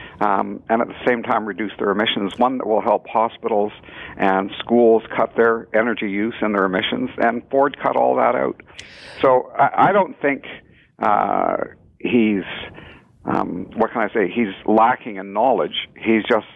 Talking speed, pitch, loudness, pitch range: 170 wpm, 110 Hz, -19 LUFS, 100-120 Hz